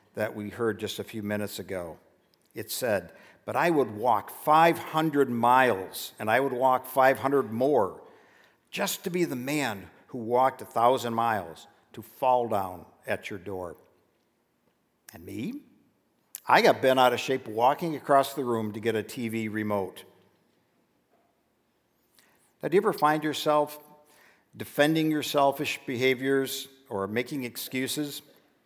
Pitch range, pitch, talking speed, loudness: 115-145 Hz, 130 Hz, 140 wpm, -27 LUFS